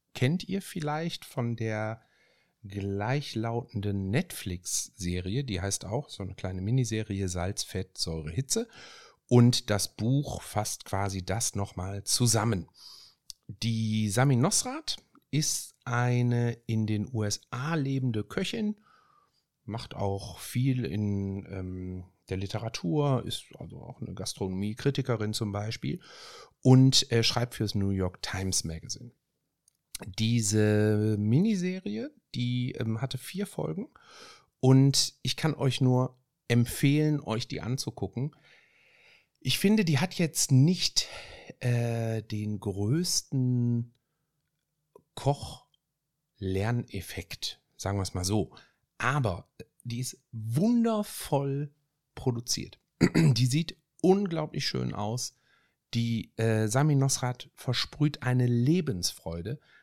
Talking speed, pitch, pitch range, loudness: 105 wpm, 120 Hz, 105-145 Hz, -29 LUFS